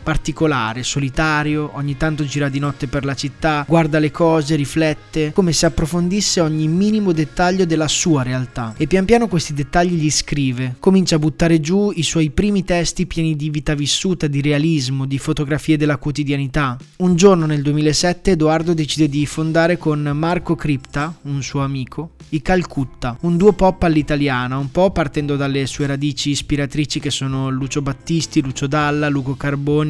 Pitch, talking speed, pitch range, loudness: 155 Hz, 165 wpm, 145-165 Hz, -18 LUFS